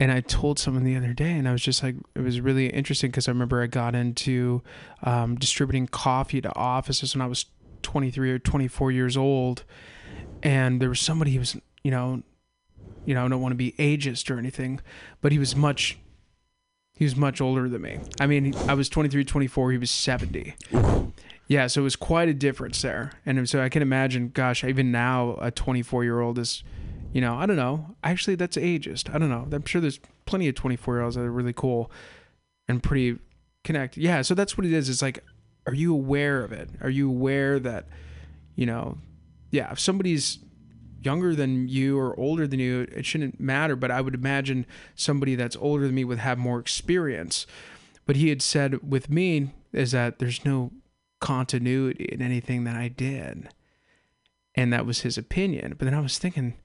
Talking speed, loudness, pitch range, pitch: 200 wpm, -26 LUFS, 125-140 Hz, 130 Hz